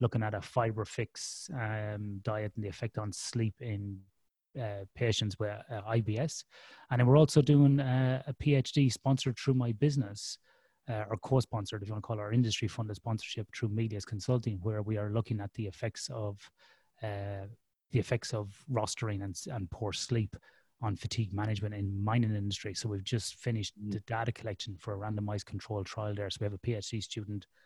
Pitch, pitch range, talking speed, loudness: 110 Hz, 105-120 Hz, 190 wpm, -34 LUFS